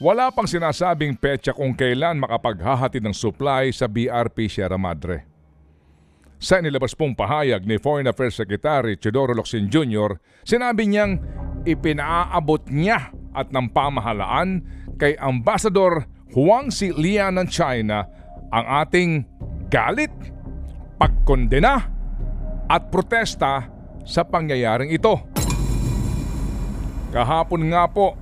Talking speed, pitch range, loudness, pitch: 105 wpm, 110-170 Hz, -21 LUFS, 135 Hz